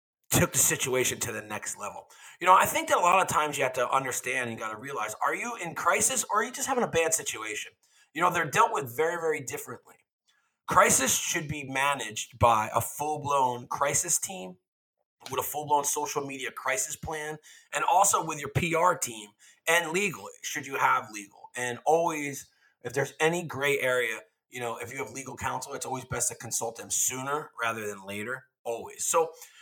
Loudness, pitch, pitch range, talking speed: -27 LUFS, 140 Hz, 115-155 Hz, 205 wpm